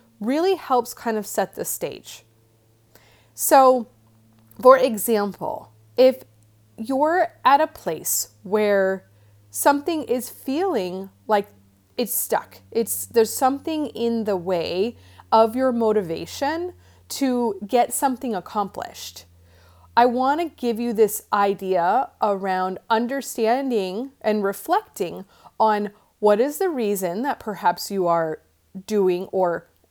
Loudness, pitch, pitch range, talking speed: -22 LUFS, 215 Hz, 170-255 Hz, 115 wpm